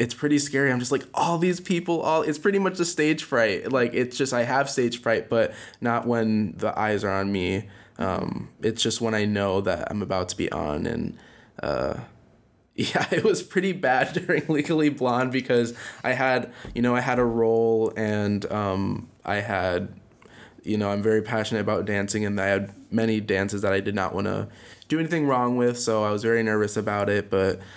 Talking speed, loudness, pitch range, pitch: 205 wpm, -24 LUFS, 105-130 Hz, 115 Hz